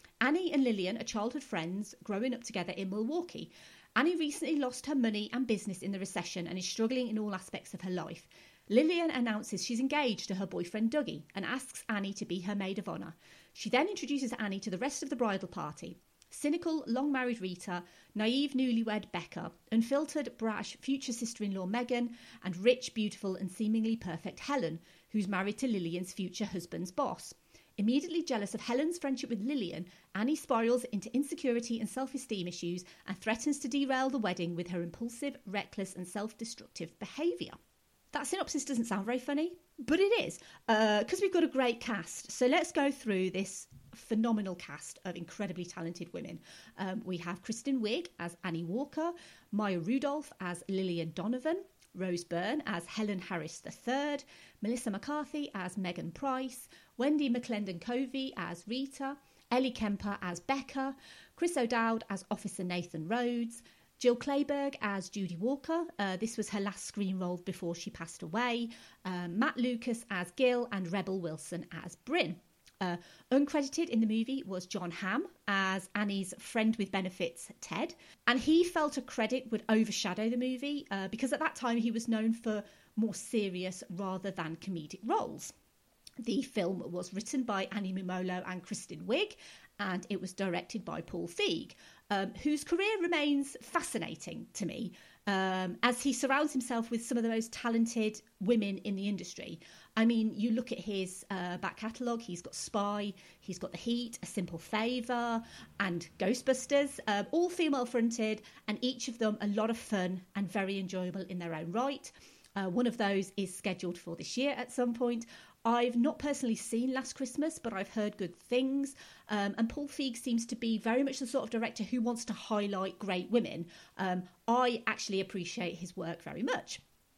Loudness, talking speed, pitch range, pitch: -35 LUFS, 175 wpm, 190-255 Hz, 220 Hz